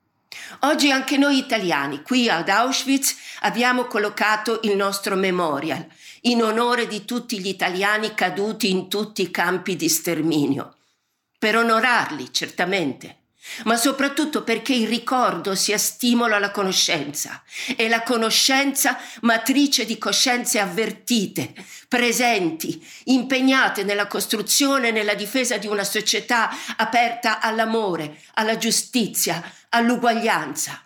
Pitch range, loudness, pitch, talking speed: 205-245 Hz, -20 LUFS, 225 Hz, 115 wpm